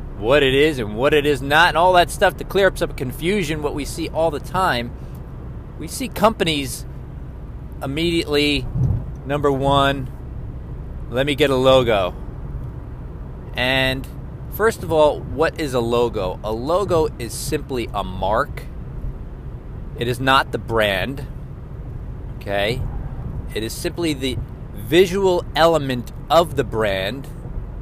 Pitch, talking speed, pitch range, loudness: 135 Hz, 135 wpm, 120-155 Hz, -19 LUFS